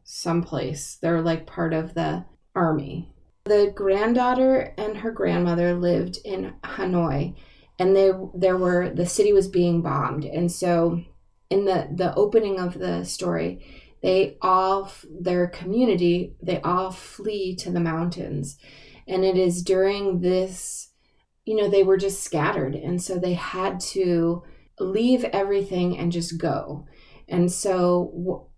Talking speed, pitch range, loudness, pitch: 140 wpm, 170-190 Hz, -23 LUFS, 180 Hz